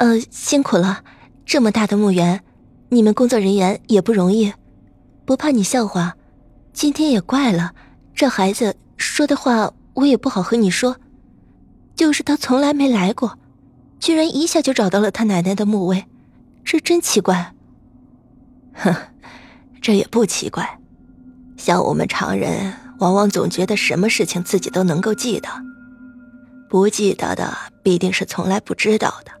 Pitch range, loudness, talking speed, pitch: 195-255 Hz, -18 LUFS, 220 characters per minute, 220 Hz